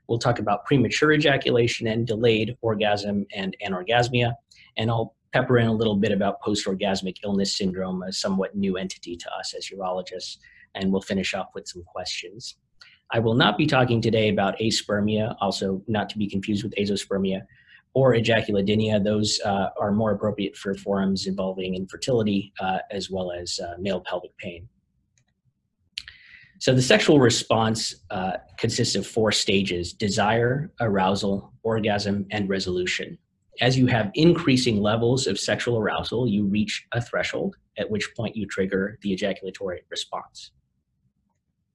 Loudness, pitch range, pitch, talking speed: -24 LUFS, 95-115 Hz, 105 Hz, 150 wpm